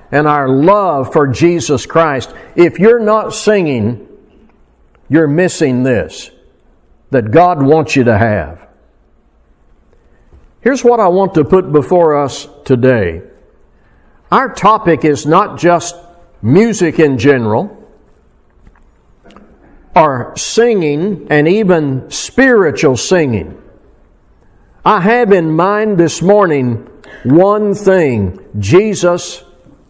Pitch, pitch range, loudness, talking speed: 160 Hz, 130-195 Hz, -11 LUFS, 100 wpm